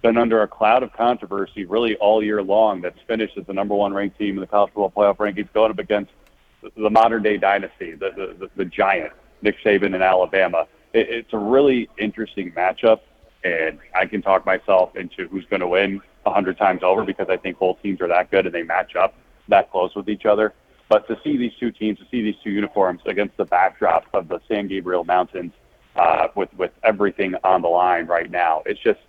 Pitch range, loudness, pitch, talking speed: 95-110 Hz, -20 LUFS, 105 Hz, 220 wpm